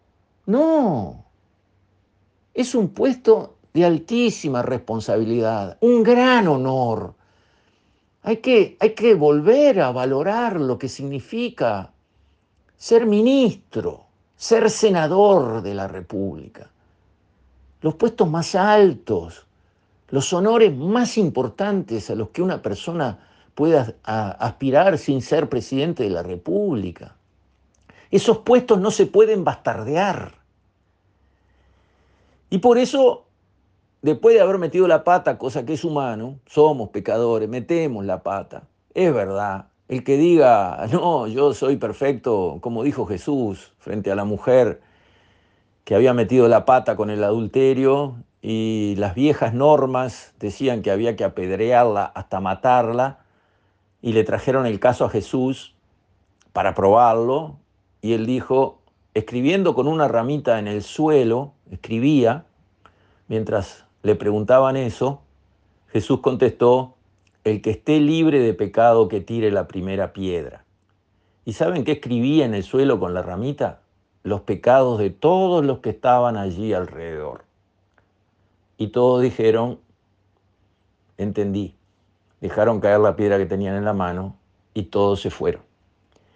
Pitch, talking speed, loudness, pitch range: 115 Hz, 125 wpm, -19 LUFS, 100-145 Hz